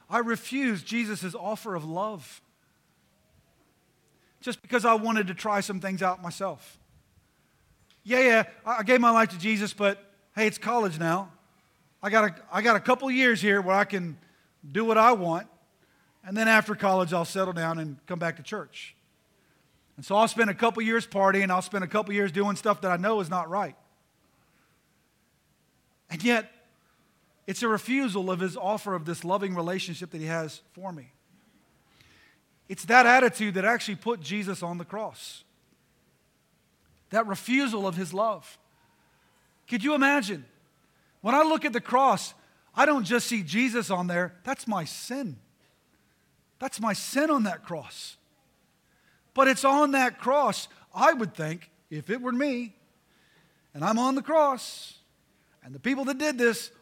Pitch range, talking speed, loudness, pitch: 180-235 Hz, 165 wpm, -26 LUFS, 205 Hz